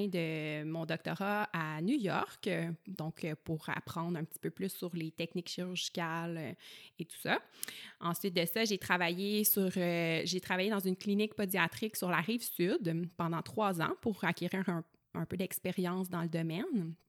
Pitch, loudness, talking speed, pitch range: 175 Hz, -36 LUFS, 170 wpm, 165-195 Hz